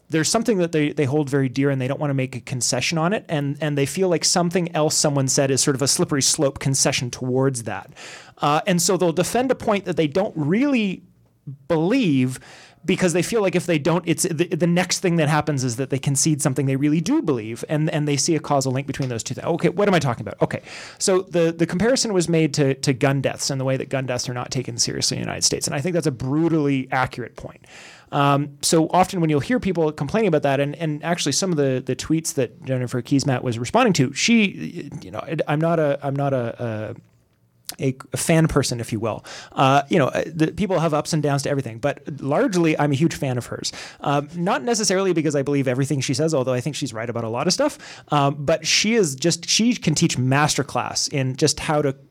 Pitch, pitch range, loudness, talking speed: 150 Hz, 135-170 Hz, -21 LUFS, 245 wpm